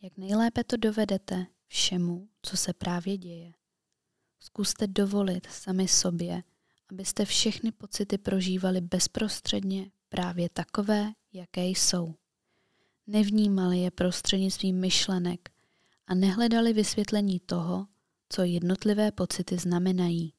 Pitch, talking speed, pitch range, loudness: 185 Hz, 100 wpm, 180-210 Hz, -28 LUFS